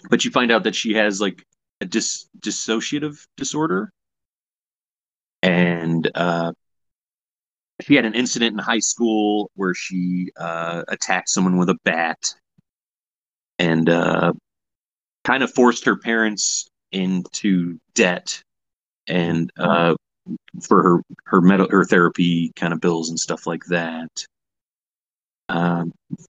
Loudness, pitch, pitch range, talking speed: -20 LUFS, 90 Hz, 85-110 Hz, 125 wpm